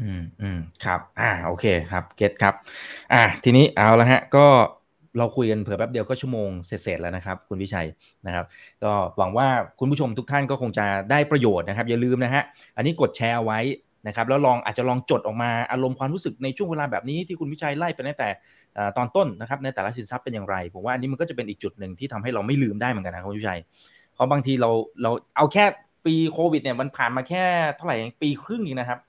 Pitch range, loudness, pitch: 105-140 Hz, -23 LUFS, 125 Hz